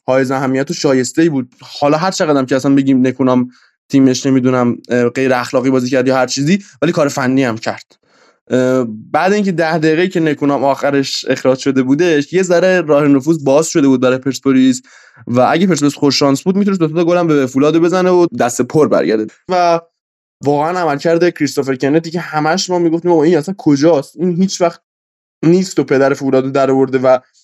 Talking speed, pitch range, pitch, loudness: 190 wpm, 130-170 Hz, 140 Hz, -13 LUFS